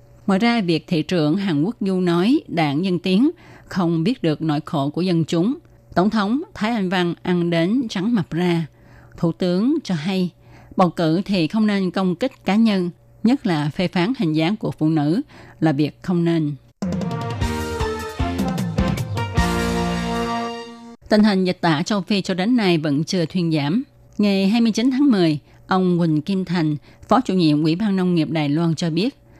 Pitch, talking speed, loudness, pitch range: 175 Hz, 180 wpm, -20 LUFS, 155-200 Hz